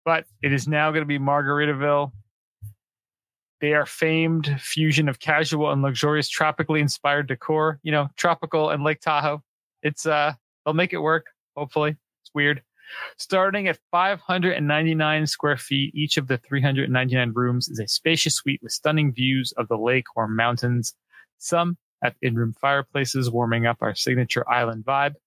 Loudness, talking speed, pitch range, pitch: -23 LUFS, 155 wpm, 130-155 Hz, 145 Hz